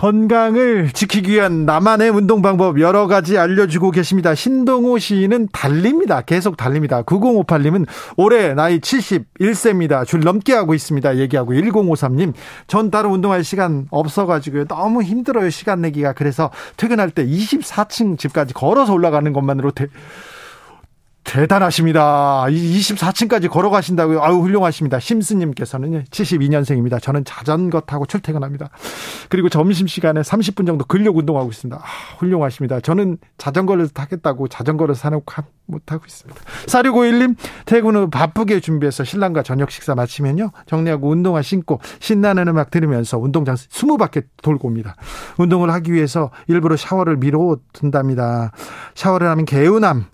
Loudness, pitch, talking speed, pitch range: -16 LUFS, 165 Hz, 350 characters per minute, 145-200 Hz